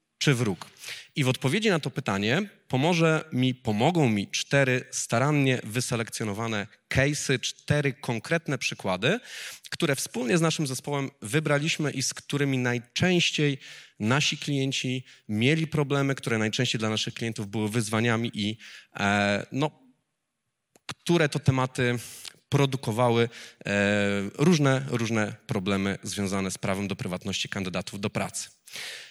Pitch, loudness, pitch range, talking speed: 130 Hz, -27 LUFS, 110-145 Hz, 120 wpm